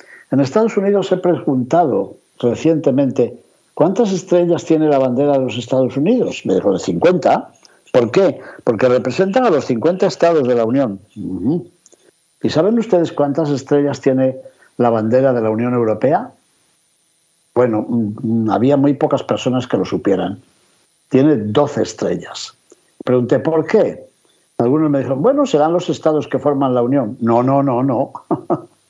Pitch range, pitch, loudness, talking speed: 125-165 Hz, 140 Hz, -16 LUFS, 145 wpm